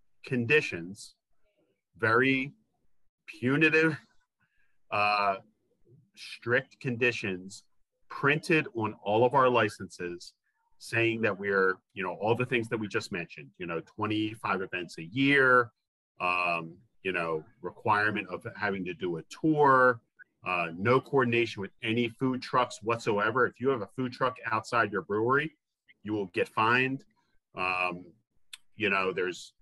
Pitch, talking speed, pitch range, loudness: 115 Hz, 130 wpm, 100-130 Hz, -28 LUFS